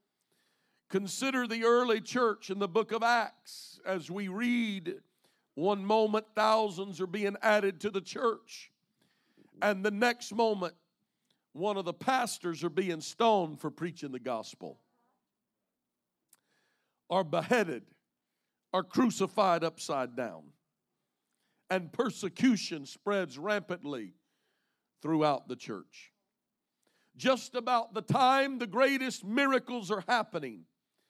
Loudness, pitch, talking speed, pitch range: -31 LUFS, 210 Hz, 110 wpm, 180-235 Hz